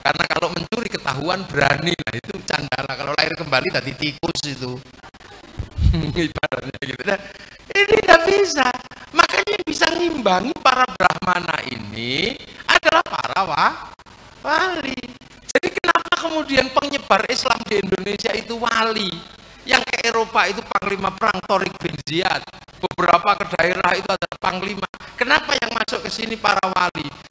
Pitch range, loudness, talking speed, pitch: 160-250 Hz, -19 LUFS, 140 wpm, 195 Hz